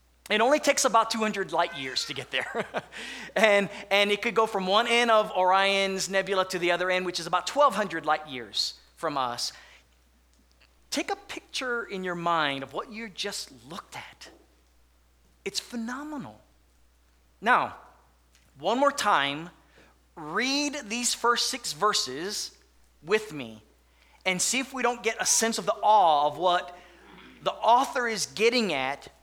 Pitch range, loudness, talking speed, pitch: 140-225 Hz, -26 LUFS, 155 wpm, 190 Hz